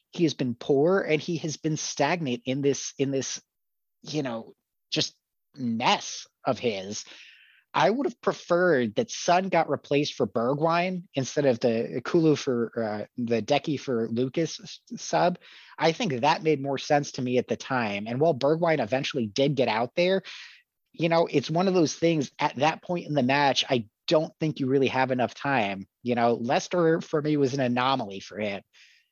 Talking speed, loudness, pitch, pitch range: 185 wpm, -26 LUFS, 140 Hz, 125-165 Hz